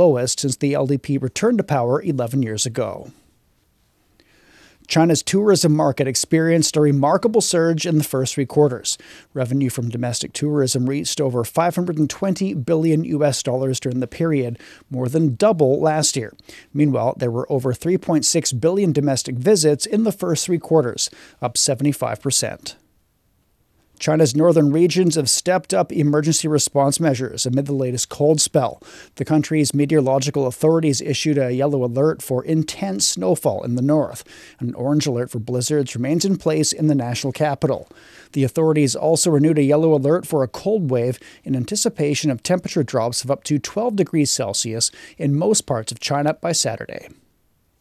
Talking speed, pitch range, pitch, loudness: 155 wpm, 130-160 Hz, 145 Hz, -19 LUFS